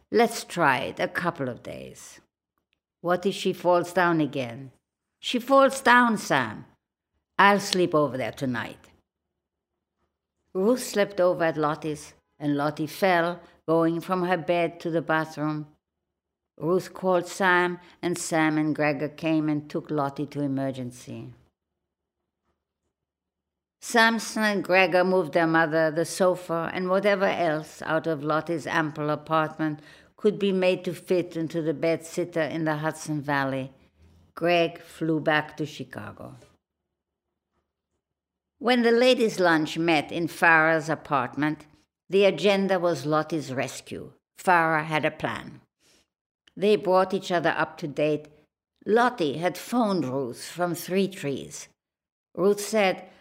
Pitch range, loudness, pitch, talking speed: 145-180 Hz, -25 LUFS, 160 Hz, 130 wpm